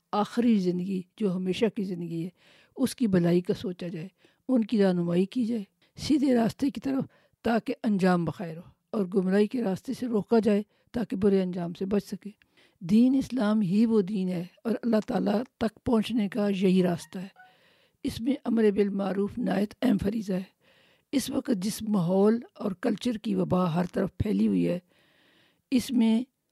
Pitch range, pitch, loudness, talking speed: 185-235 Hz, 210 Hz, -27 LUFS, 175 wpm